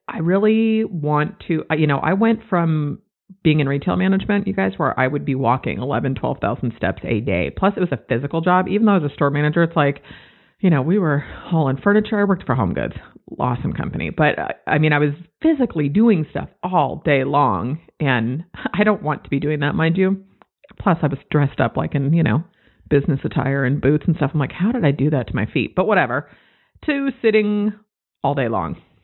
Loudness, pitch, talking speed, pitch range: -19 LUFS, 155 Hz, 220 wpm, 140-195 Hz